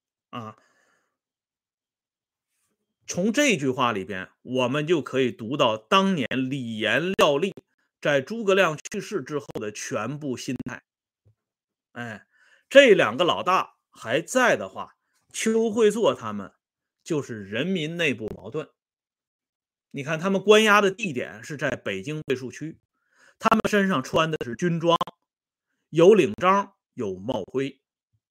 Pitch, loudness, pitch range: 155 Hz, -23 LUFS, 125-195 Hz